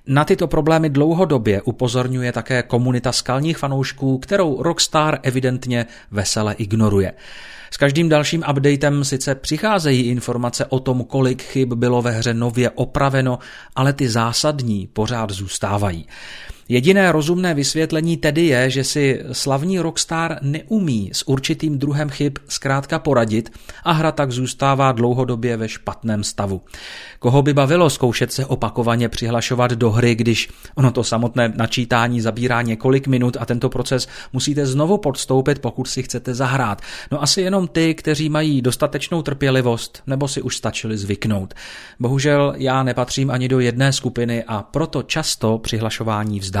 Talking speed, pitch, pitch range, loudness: 145 wpm, 130 Hz, 120-145 Hz, -19 LUFS